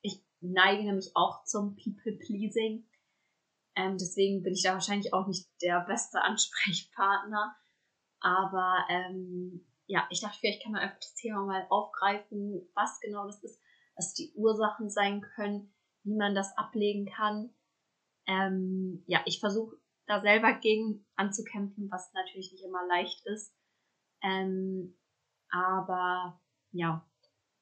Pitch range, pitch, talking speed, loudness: 185-210 Hz, 195 Hz, 130 wpm, -32 LUFS